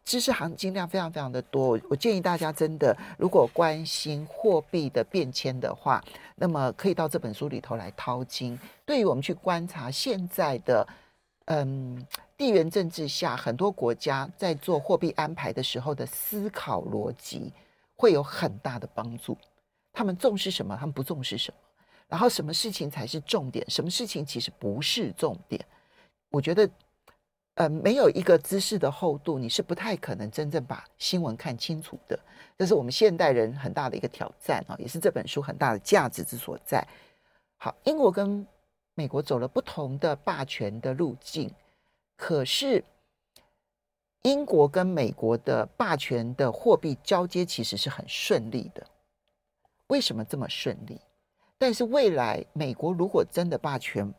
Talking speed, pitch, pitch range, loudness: 255 characters per minute, 160 Hz, 135-190 Hz, -28 LUFS